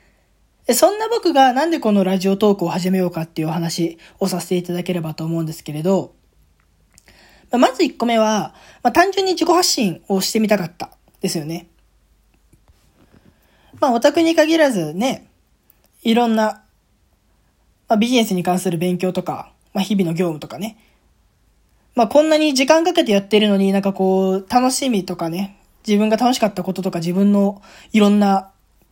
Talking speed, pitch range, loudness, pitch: 325 characters per minute, 170-235 Hz, -18 LUFS, 195 Hz